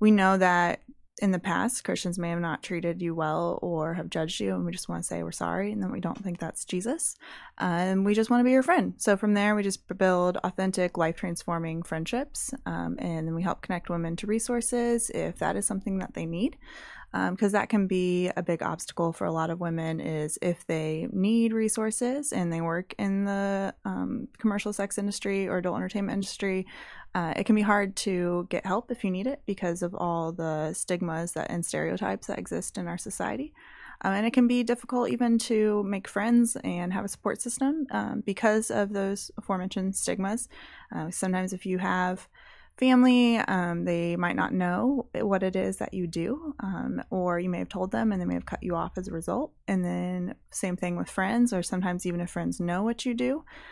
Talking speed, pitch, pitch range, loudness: 215 wpm, 190 Hz, 175-225 Hz, -28 LUFS